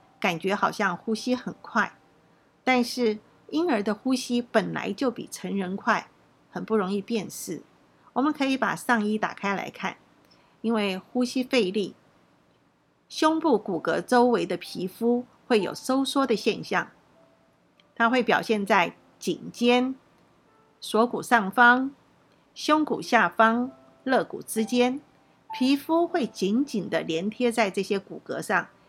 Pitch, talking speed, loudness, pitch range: 230 Hz, 195 characters per minute, -25 LUFS, 205-250 Hz